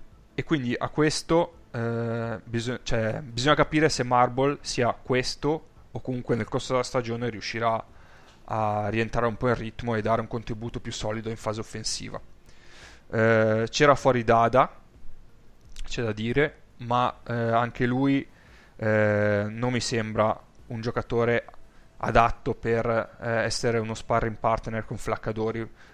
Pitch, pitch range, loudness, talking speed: 115 Hz, 110-125 Hz, -26 LUFS, 140 wpm